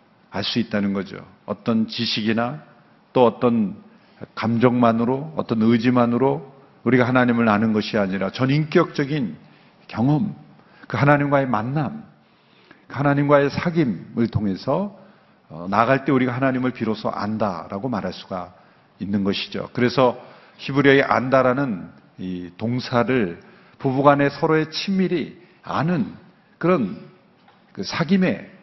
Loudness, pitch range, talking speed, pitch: -21 LUFS, 115-160 Hz, 270 characters per minute, 130 Hz